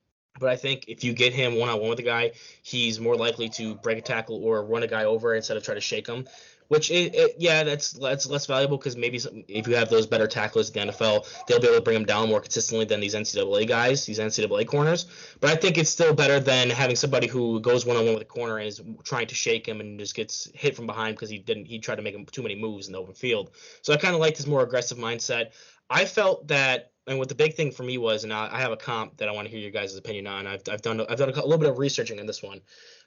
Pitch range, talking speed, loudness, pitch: 115-160 Hz, 290 wpm, -25 LUFS, 125 Hz